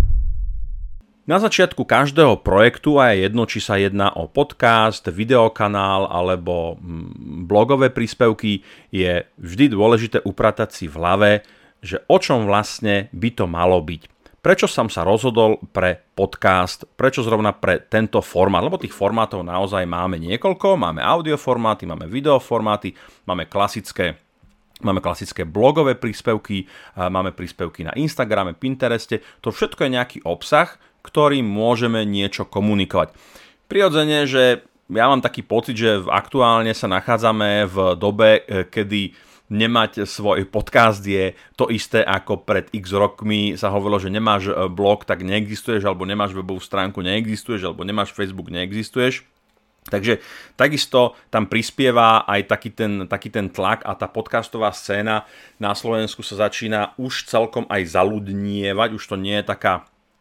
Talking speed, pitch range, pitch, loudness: 140 wpm, 95-115 Hz, 105 Hz, -19 LUFS